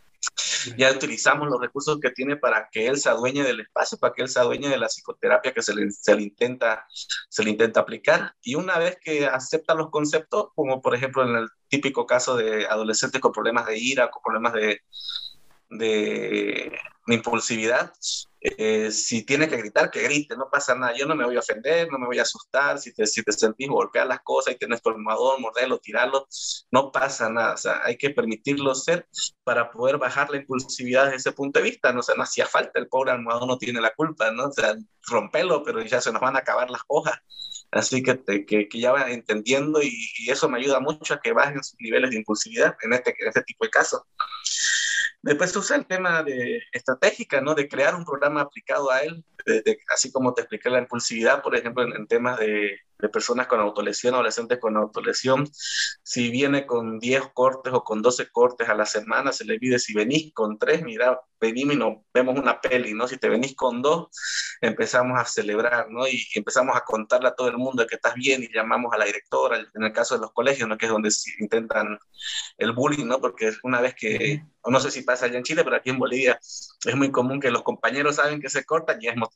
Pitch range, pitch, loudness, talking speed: 115-150 Hz, 130 Hz, -23 LUFS, 225 wpm